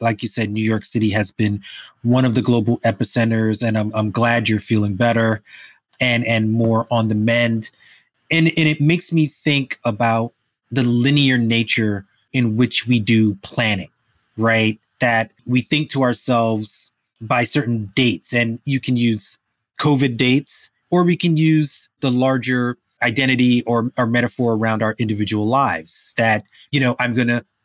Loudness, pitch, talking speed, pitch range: -18 LUFS, 120 Hz, 165 wpm, 110-130 Hz